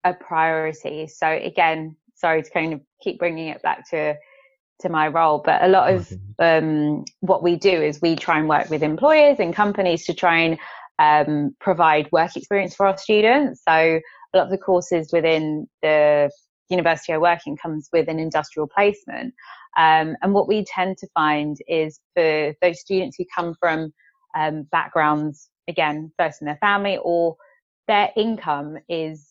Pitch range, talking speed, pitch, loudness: 155-185 Hz, 175 wpm, 165 Hz, -20 LUFS